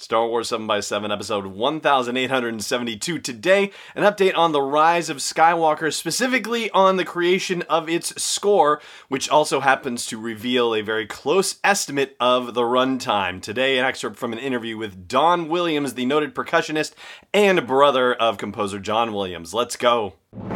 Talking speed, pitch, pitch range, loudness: 150 wpm, 140 Hz, 115-170 Hz, -21 LUFS